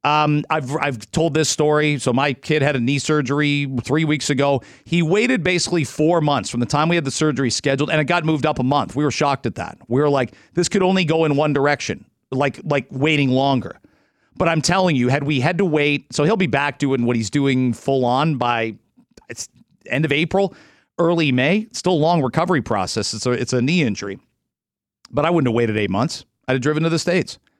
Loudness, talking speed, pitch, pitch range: -19 LUFS, 230 wpm, 145 Hz, 130-160 Hz